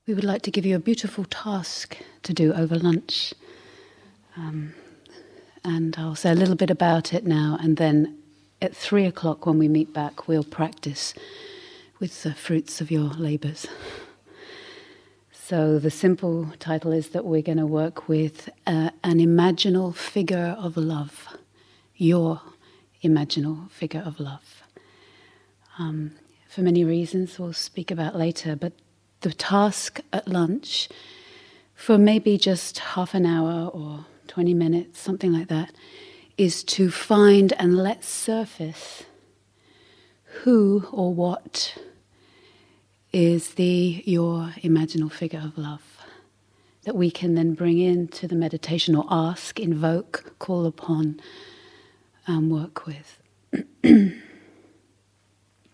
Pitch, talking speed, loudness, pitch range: 170 Hz, 130 wpm, -23 LUFS, 160-200 Hz